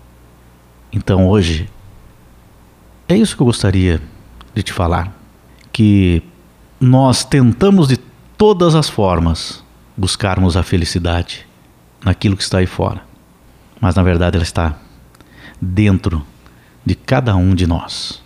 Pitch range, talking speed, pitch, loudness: 85-105 Hz, 120 wpm, 95 Hz, -15 LUFS